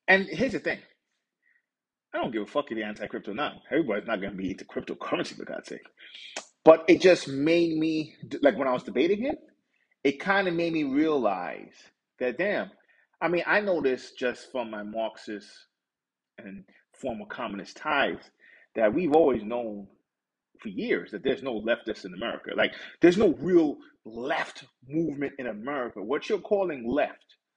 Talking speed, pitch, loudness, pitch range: 170 wpm, 155 Hz, -27 LUFS, 125-185 Hz